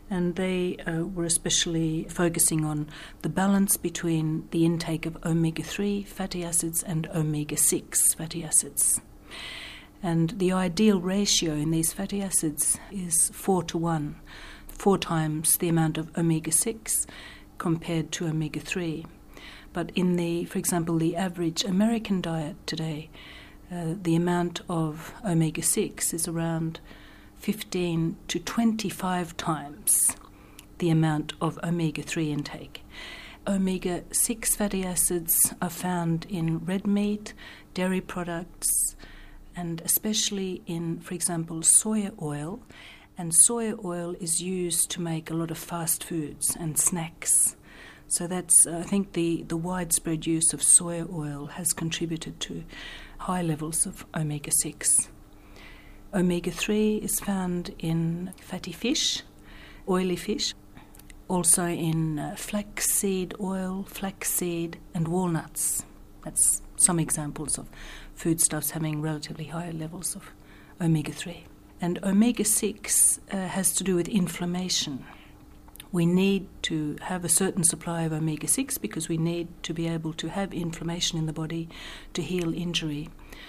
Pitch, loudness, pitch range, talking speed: 170 Hz, -26 LUFS, 160-185 Hz, 135 wpm